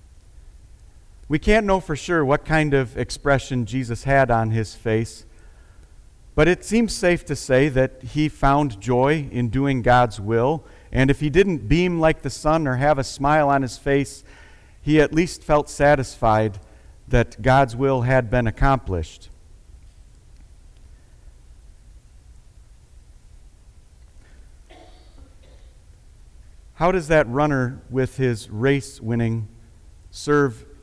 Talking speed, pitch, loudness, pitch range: 125 wpm, 125 Hz, -21 LUFS, 90-140 Hz